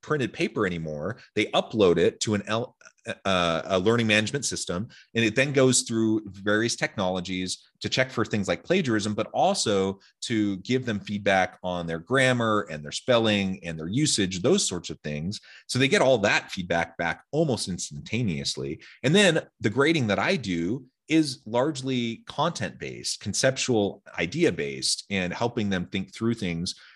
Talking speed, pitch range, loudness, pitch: 165 wpm, 90-120 Hz, -25 LUFS, 105 Hz